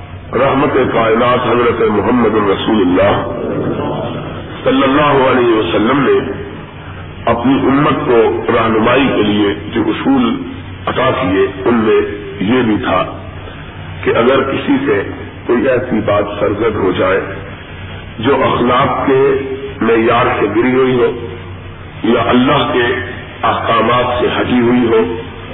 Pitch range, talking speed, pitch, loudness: 95-125 Hz, 120 wpm, 115 Hz, -13 LUFS